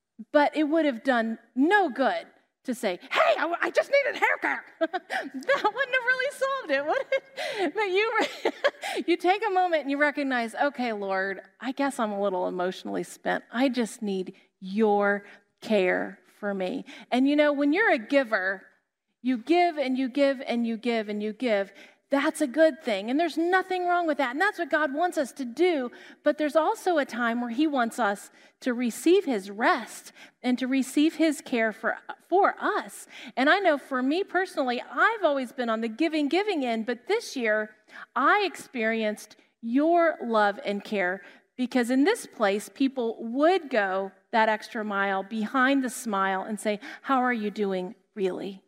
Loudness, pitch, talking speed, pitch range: -26 LUFS, 265 Hz, 185 wpm, 215-320 Hz